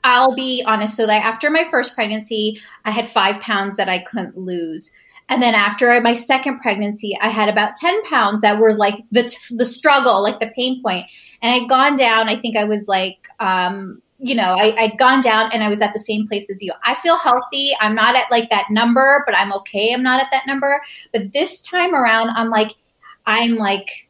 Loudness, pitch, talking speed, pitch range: -16 LUFS, 225 Hz, 220 wpm, 210-255 Hz